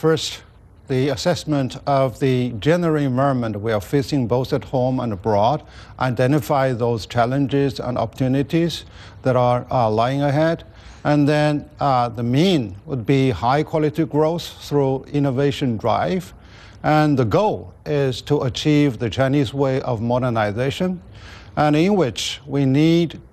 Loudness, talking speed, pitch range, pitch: -20 LUFS, 140 wpm, 120-150 Hz, 135 Hz